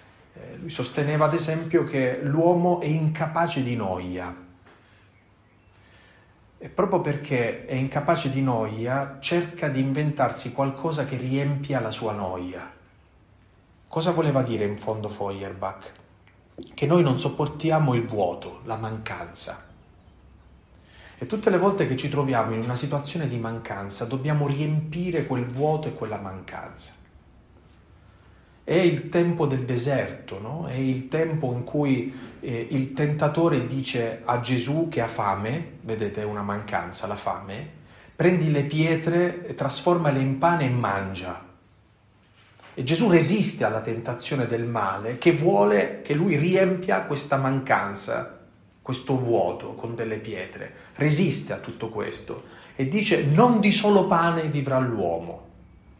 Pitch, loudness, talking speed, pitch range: 130 Hz, -25 LUFS, 135 wpm, 105-150 Hz